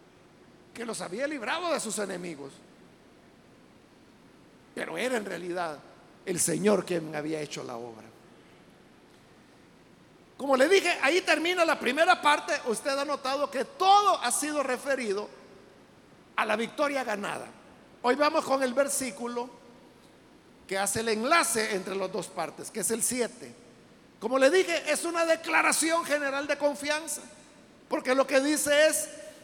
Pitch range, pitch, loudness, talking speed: 215-300 Hz, 270 Hz, -27 LUFS, 140 wpm